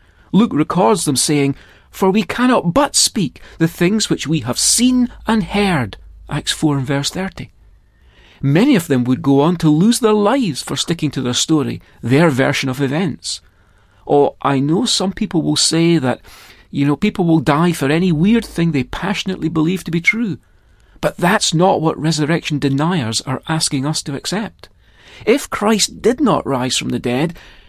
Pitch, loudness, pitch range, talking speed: 160 Hz, -16 LUFS, 140-190 Hz, 180 wpm